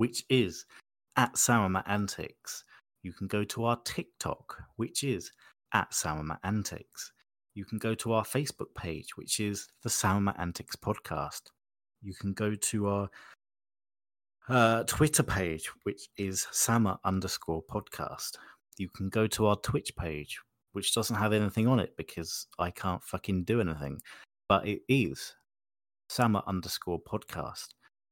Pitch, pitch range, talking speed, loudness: 100 Hz, 95-115 Hz, 145 wpm, -31 LUFS